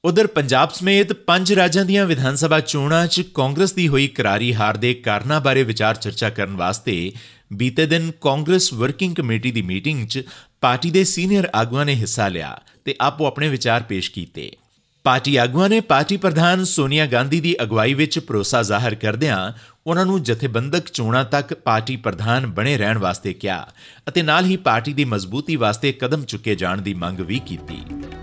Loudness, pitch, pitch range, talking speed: -19 LUFS, 130 Hz, 110-165 Hz, 170 wpm